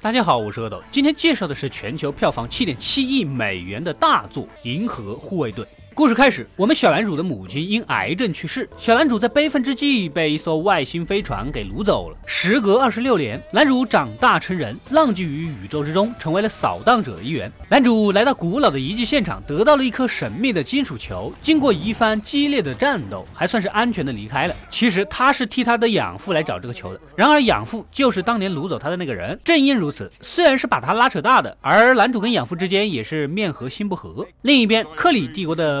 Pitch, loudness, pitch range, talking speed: 215 Hz, -19 LUFS, 165-260 Hz, 335 characters per minute